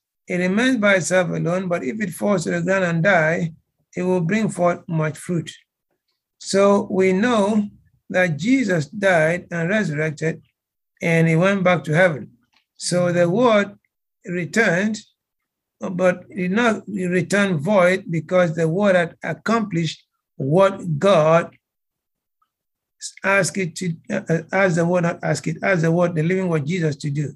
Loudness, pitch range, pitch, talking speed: -20 LUFS, 165-195 Hz, 180 Hz, 150 wpm